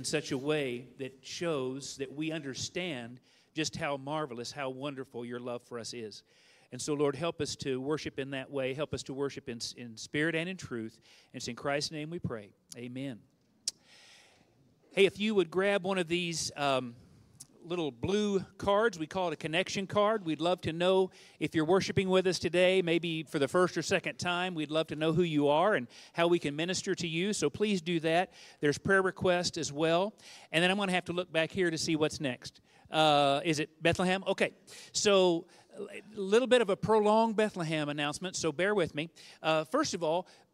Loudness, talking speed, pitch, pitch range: -31 LUFS, 210 wpm, 160 Hz, 140-185 Hz